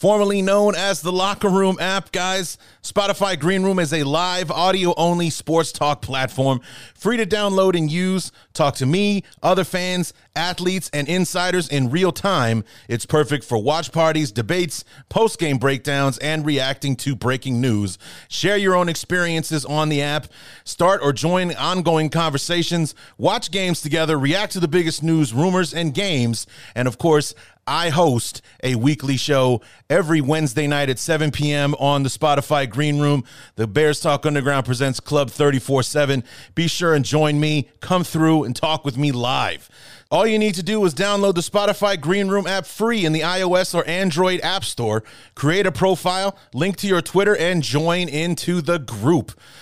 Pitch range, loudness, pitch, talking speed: 140-180 Hz, -20 LUFS, 160 Hz, 170 wpm